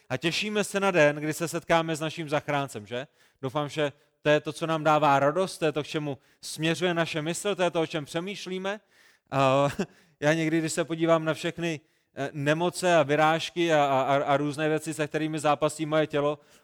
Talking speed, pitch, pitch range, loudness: 190 wpm, 155 Hz, 145-170 Hz, -27 LUFS